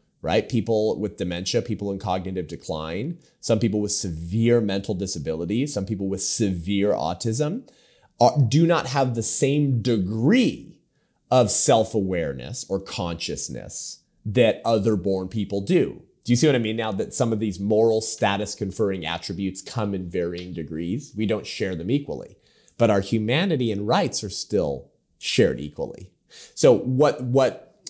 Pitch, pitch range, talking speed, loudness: 110 Hz, 95-120 Hz, 155 wpm, -23 LUFS